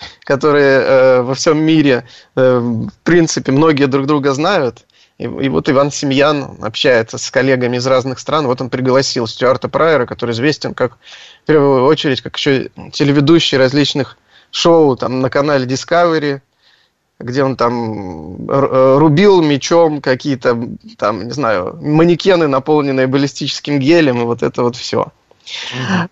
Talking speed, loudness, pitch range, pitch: 140 wpm, -13 LUFS, 130-150 Hz, 140 Hz